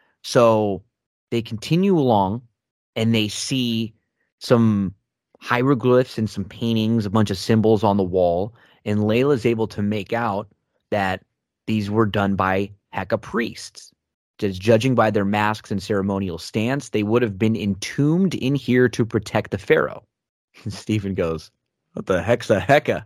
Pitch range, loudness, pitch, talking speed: 100-120 Hz, -21 LUFS, 110 Hz, 155 wpm